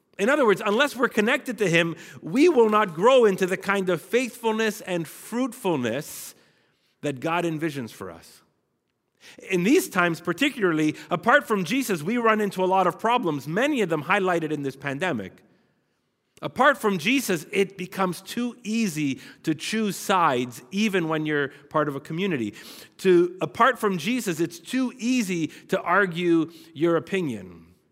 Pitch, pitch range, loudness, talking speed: 185 Hz, 165-225 Hz, -24 LUFS, 155 wpm